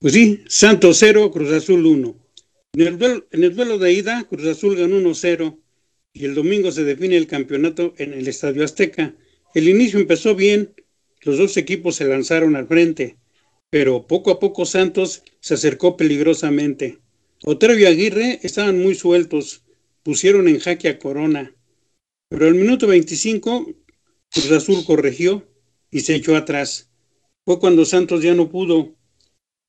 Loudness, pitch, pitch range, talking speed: -16 LUFS, 175 Hz, 155-205 Hz, 150 wpm